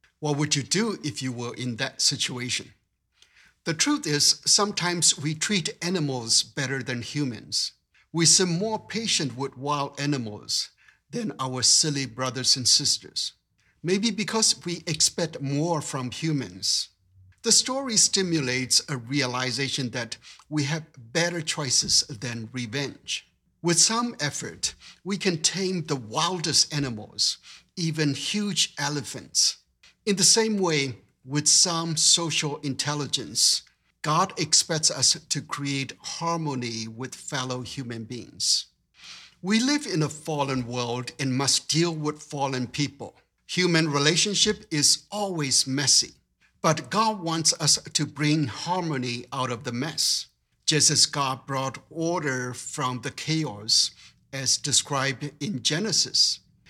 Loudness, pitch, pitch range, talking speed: -24 LUFS, 145 Hz, 130-165 Hz, 130 wpm